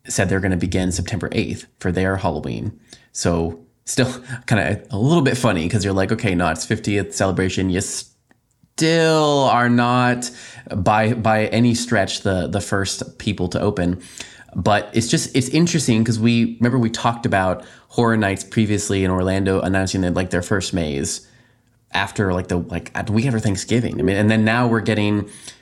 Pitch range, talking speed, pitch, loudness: 95-120 Hz, 185 wpm, 105 Hz, -19 LUFS